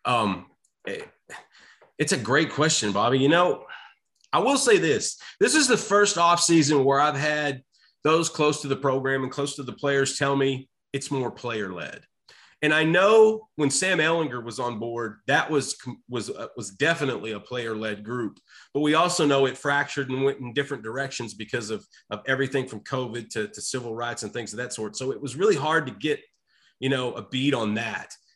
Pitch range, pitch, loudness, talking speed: 120-155 Hz, 140 Hz, -24 LUFS, 205 wpm